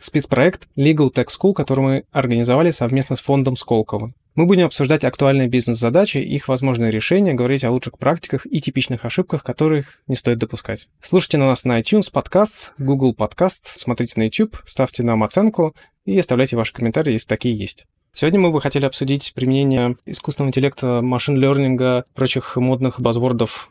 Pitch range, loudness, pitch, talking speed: 120-150 Hz, -18 LUFS, 130 Hz, 160 wpm